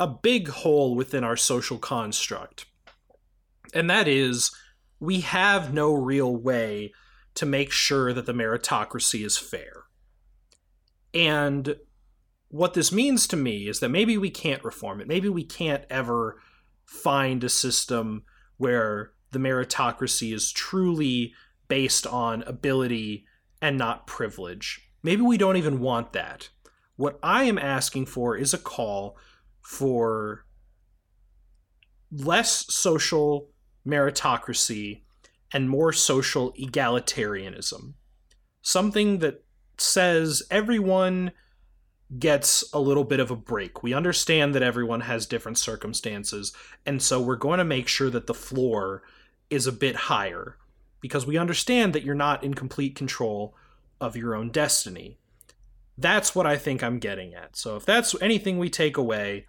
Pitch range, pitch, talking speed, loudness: 115-150 Hz, 135 Hz, 135 wpm, -25 LUFS